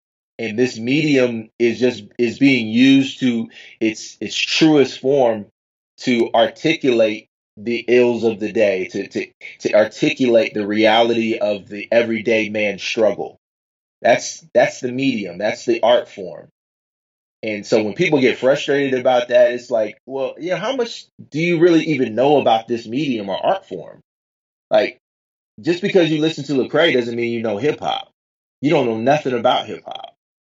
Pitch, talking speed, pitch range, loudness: 120 Hz, 170 wpm, 115-140 Hz, -18 LUFS